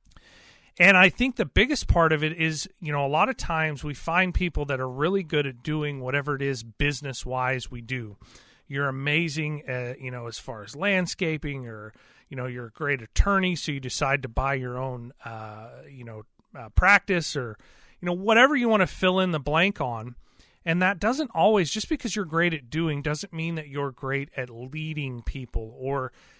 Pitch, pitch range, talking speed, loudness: 145 Hz, 130-175 Hz, 205 wpm, -25 LUFS